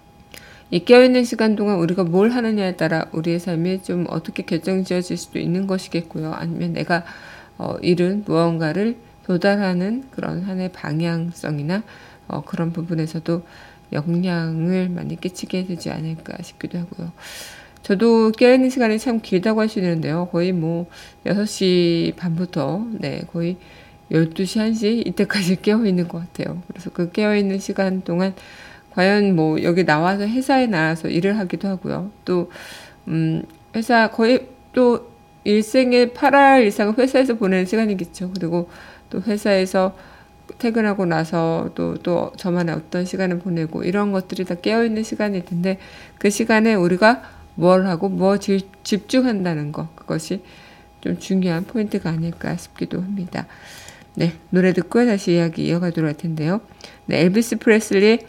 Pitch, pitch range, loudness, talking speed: 185 Hz, 170-210 Hz, -20 LUFS, 315 characters per minute